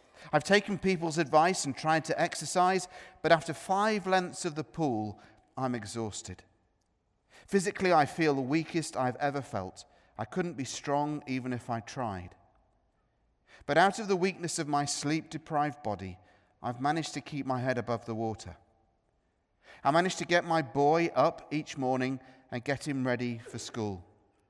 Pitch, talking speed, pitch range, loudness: 140 Hz, 165 wpm, 110-165 Hz, -31 LUFS